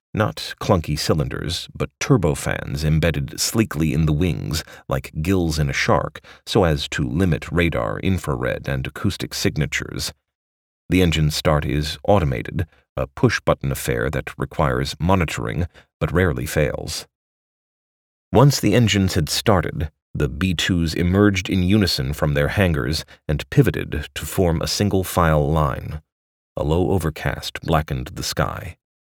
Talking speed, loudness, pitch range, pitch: 135 wpm, -21 LUFS, 70-90 Hz, 80 Hz